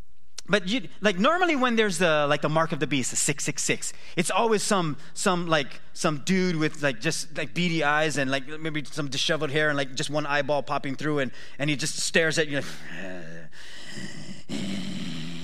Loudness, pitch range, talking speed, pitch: -26 LUFS, 140-170 Hz, 190 wpm, 155 Hz